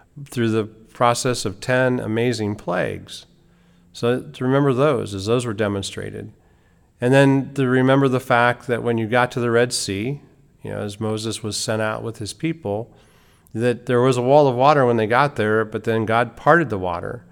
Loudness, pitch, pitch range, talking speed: -20 LUFS, 120 Hz, 110-130 Hz, 195 wpm